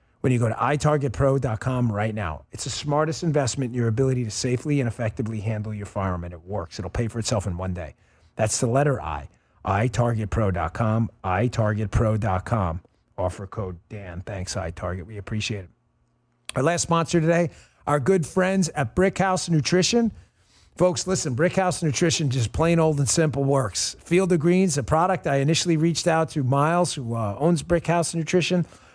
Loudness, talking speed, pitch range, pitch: -23 LUFS, 170 wpm, 110-160 Hz, 130 Hz